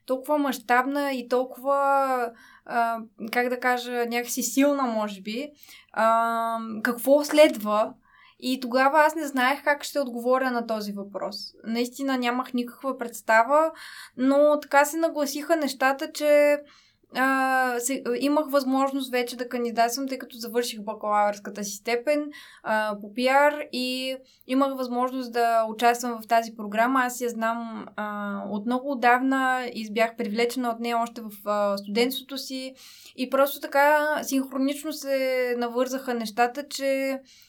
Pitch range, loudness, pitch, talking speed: 235-275 Hz, -25 LUFS, 255 Hz, 125 wpm